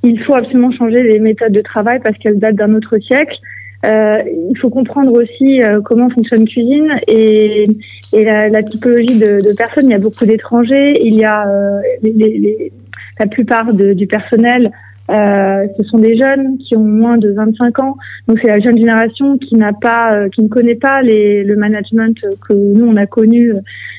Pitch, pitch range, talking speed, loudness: 220 Hz, 210-240 Hz, 200 wpm, -10 LUFS